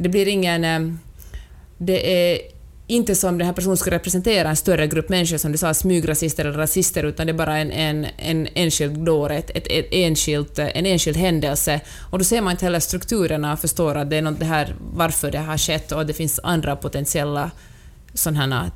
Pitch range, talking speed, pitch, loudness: 150-180 Hz, 190 wpm, 160 Hz, -20 LUFS